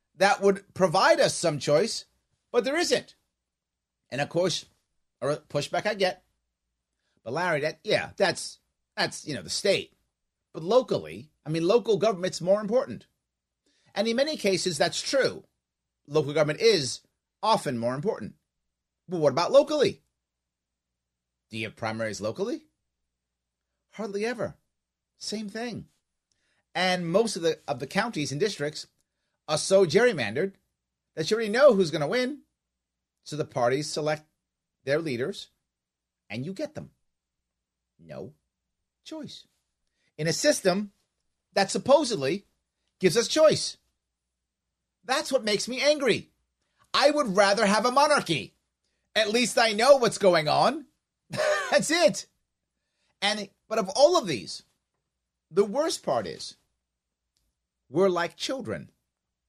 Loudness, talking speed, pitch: -26 LUFS, 130 wpm, 170 Hz